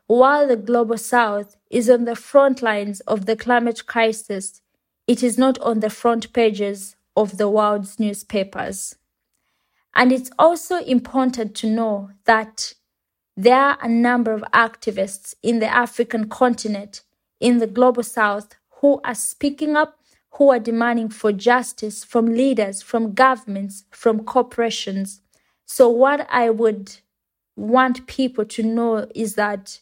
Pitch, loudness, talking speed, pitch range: 230 Hz, -19 LUFS, 140 wpm, 215-250 Hz